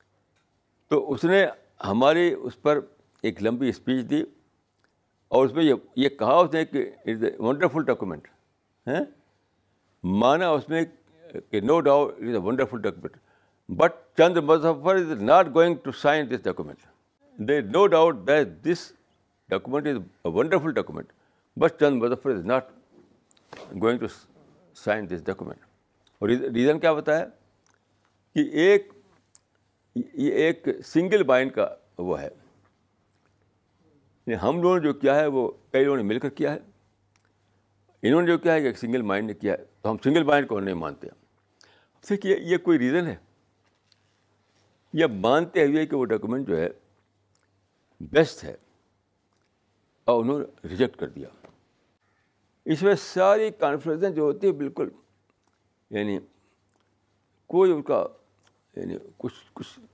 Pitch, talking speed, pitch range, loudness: 130 Hz, 145 wpm, 100-165 Hz, -24 LUFS